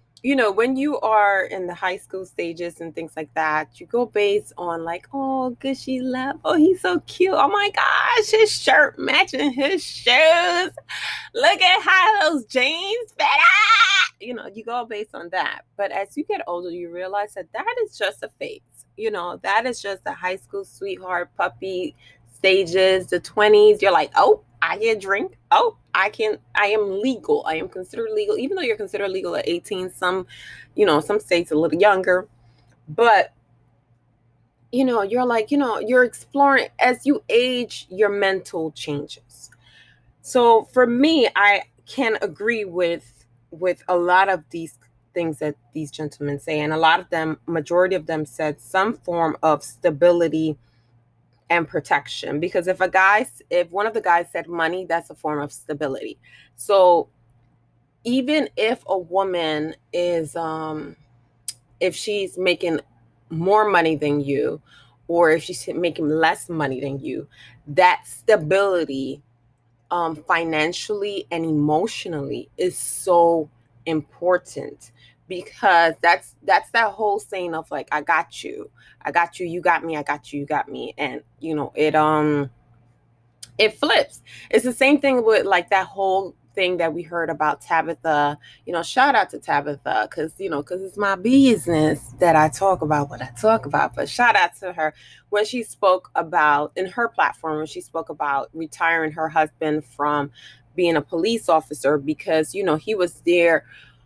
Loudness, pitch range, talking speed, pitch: -20 LUFS, 150-220 Hz, 170 wpm, 175 Hz